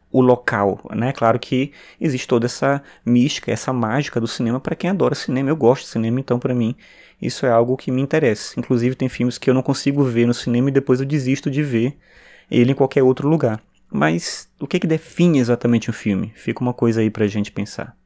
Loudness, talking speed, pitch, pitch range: -19 LUFS, 225 wpm, 125 Hz, 115-140 Hz